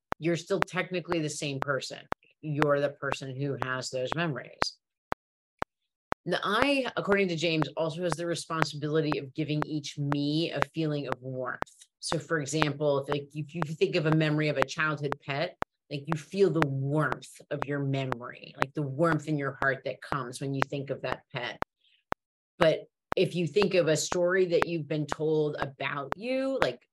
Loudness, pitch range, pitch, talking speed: -30 LUFS, 140-165 Hz, 150 Hz, 180 wpm